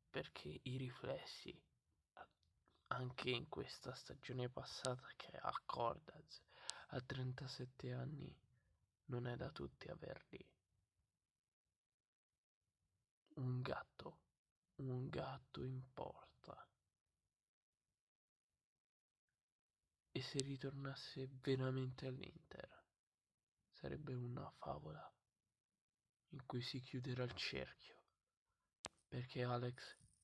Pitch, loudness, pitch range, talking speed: 125 Hz, -49 LUFS, 95-130 Hz, 80 wpm